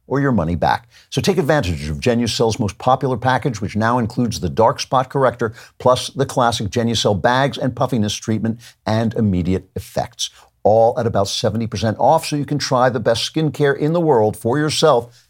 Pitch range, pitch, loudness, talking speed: 110-130 Hz, 120 Hz, -18 LUFS, 185 wpm